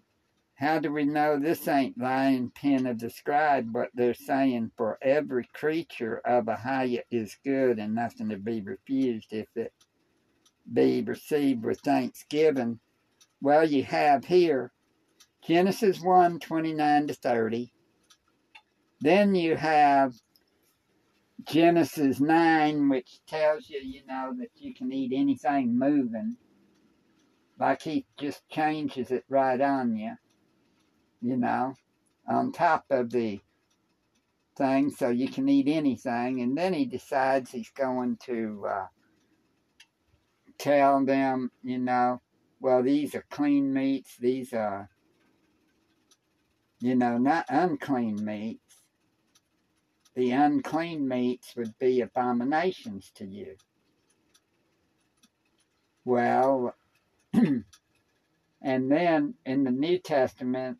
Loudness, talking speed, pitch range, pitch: -27 LUFS, 115 wpm, 125-165 Hz, 135 Hz